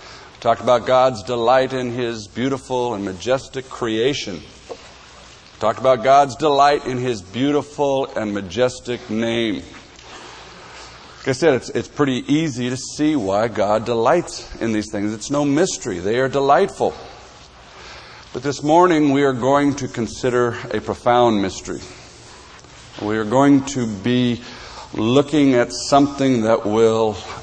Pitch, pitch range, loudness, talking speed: 125 Hz, 115-140 Hz, -19 LUFS, 135 wpm